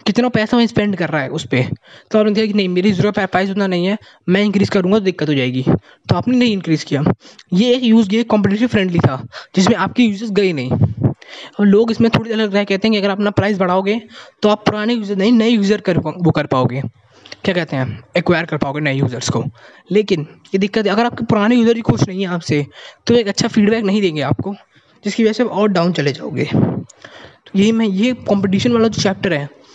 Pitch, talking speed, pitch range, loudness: 200 Hz, 230 wpm, 155-215 Hz, -16 LUFS